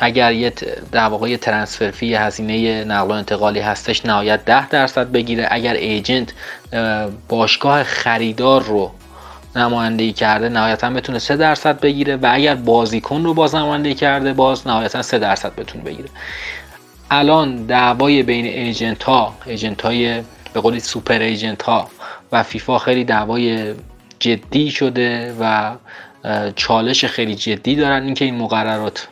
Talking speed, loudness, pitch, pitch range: 135 wpm, -16 LUFS, 115 Hz, 110-130 Hz